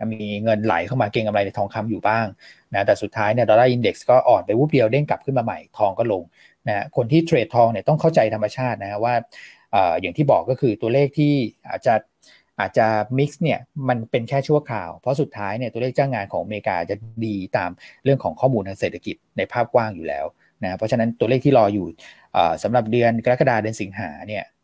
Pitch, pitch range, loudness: 115 Hz, 105-130 Hz, -21 LUFS